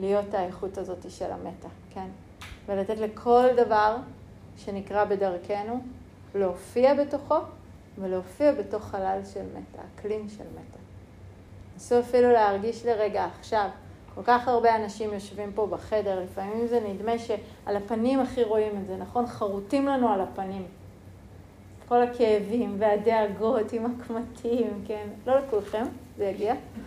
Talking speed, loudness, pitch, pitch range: 125 wpm, -27 LUFS, 210 Hz, 190-235 Hz